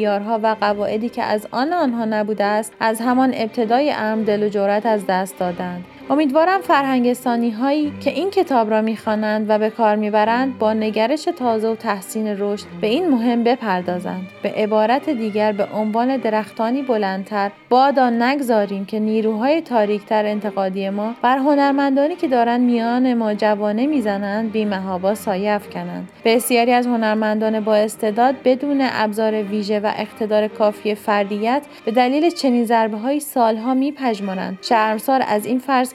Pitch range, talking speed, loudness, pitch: 210-250 Hz, 145 wpm, -19 LUFS, 220 Hz